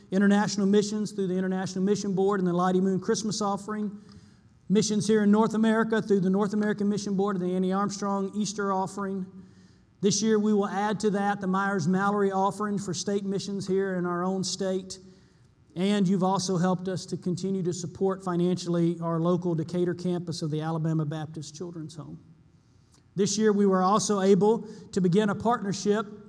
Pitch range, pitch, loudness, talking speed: 180-205 Hz, 195 Hz, -27 LUFS, 180 wpm